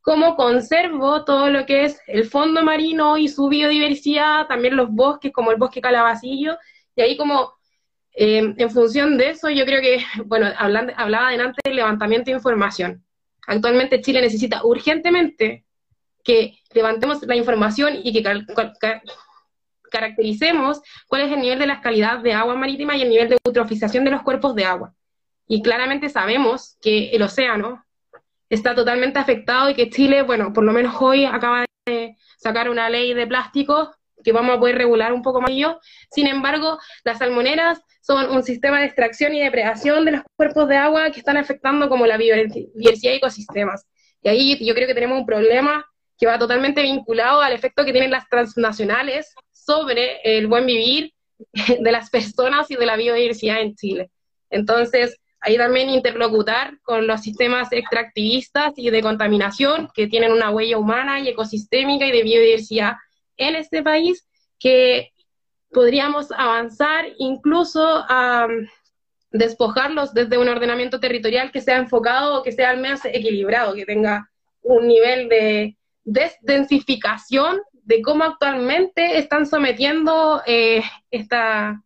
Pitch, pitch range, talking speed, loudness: 250 Hz, 230-285 Hz, 160 wpm, -18 LUFS